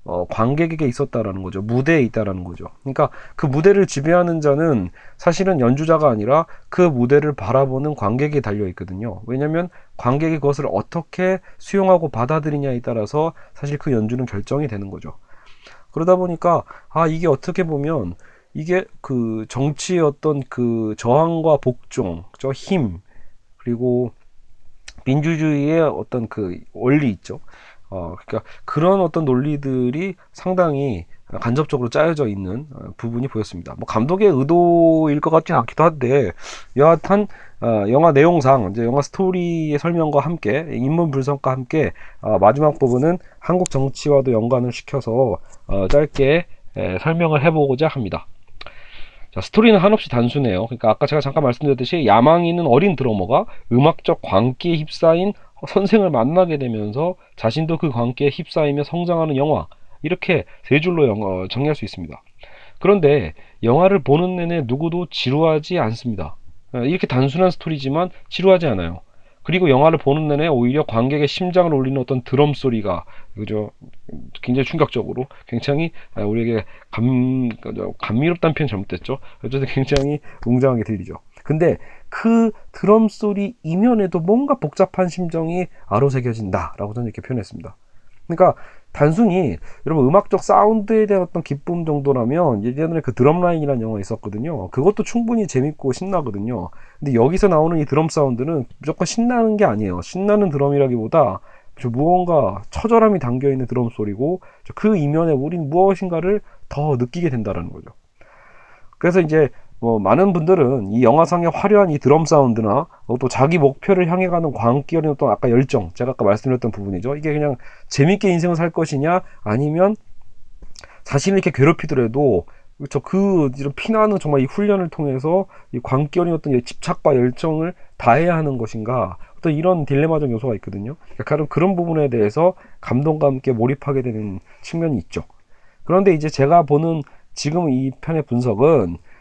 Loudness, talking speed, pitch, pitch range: -18 LUFS, 345 characters per minute, 140 Hz, 120-170 Hz